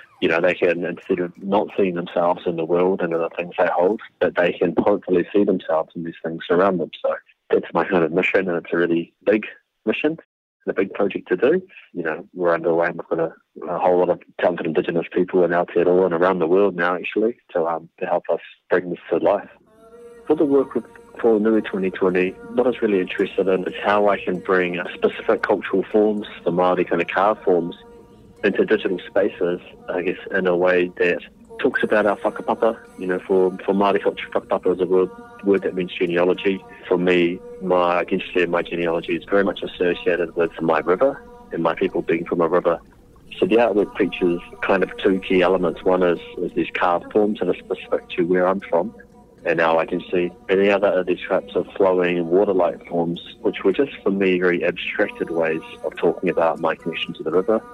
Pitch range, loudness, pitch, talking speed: 85-100 Hz, -21 LUFS, 90 Hz, 215 wpm